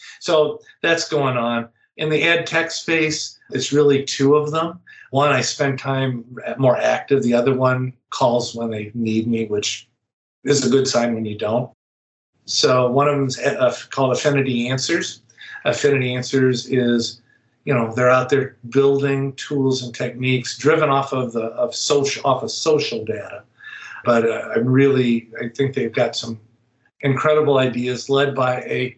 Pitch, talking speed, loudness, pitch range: 130 Hz, 165 wpm, -19 LUFS, 120-140 Hz